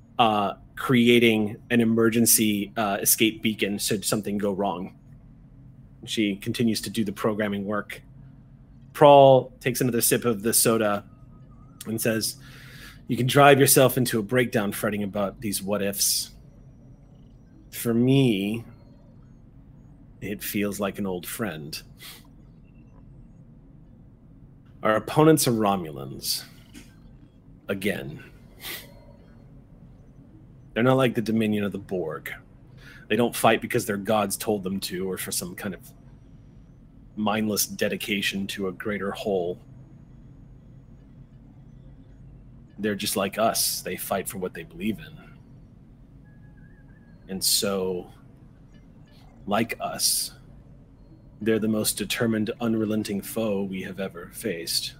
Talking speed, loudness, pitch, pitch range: 115 wpm, -24 LUFS, 120 Hz, 105-135 Hz